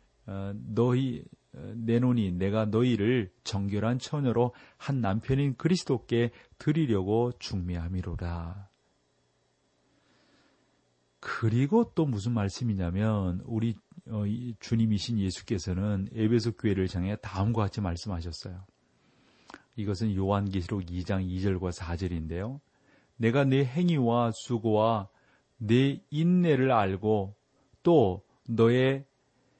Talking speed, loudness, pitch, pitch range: 220 characters per minute, -29 LUFS, 110 Hz, 95-120 Hz